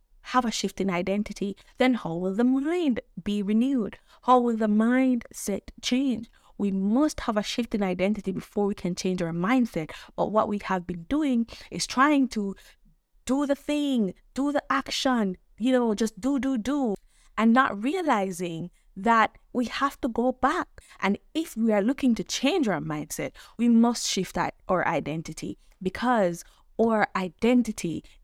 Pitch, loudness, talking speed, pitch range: 220 Hz, -26 LUFS, 165 wpm, 190-255 Hz